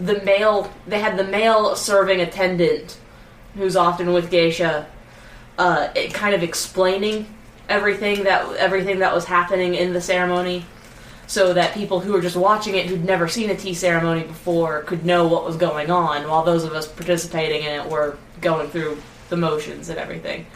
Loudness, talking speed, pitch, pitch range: -20 LUFS, 180 wpm, 180 Hz, 165-195 Hz